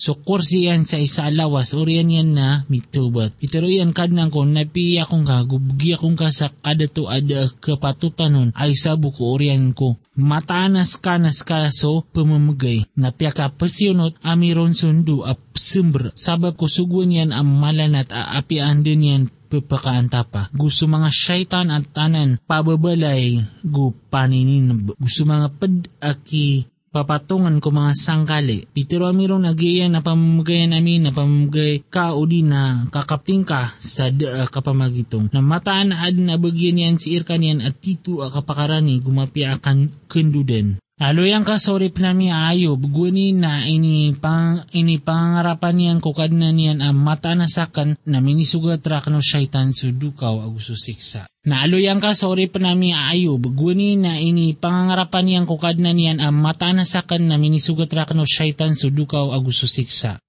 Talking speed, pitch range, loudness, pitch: 140 wpm, 140-170 Hz, -18 LUFS, 155 Hz